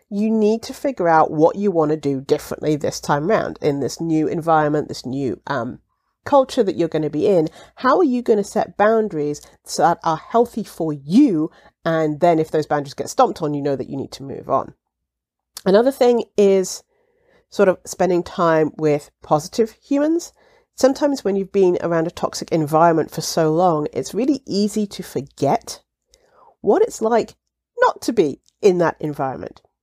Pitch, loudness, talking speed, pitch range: 180 Hz, -19 LUFS, 185 wpm, 155-240 Hz